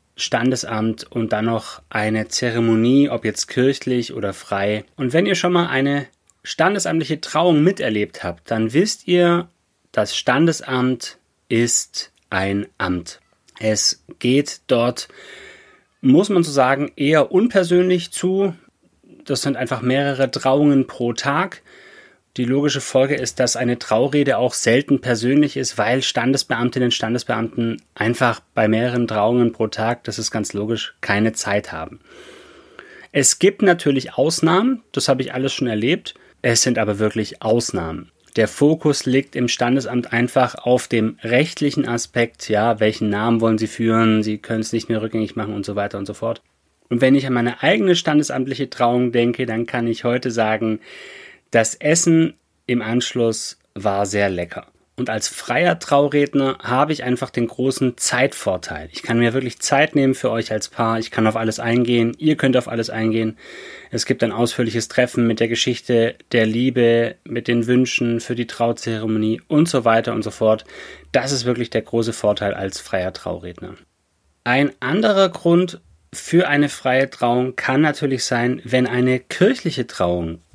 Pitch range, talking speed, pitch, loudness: 115-140 Hz, 160 wpm, 125 Hz, -19 LUFS